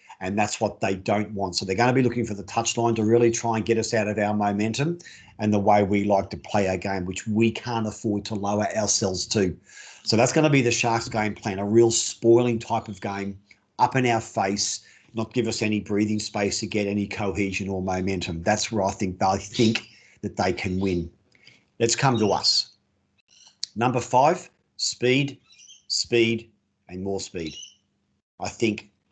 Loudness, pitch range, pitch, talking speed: -24 LUFS, 100-115 Hz, 105 Hz, 195 wpm